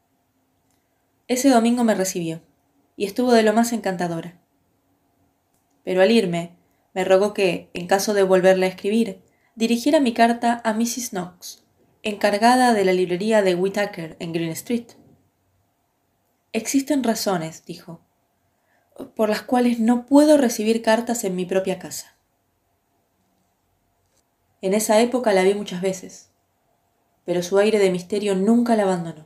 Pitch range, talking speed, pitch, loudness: 170-225 Hz, 135 wpm, 195 Hz, -20 LUFS